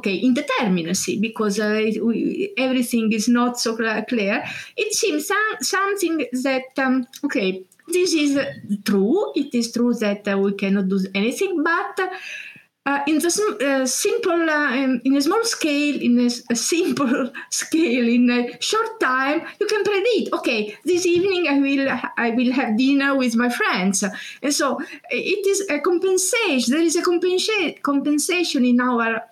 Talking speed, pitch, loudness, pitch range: 160 wpm, 275 Hz, -20 LUFS, 240-345 Hz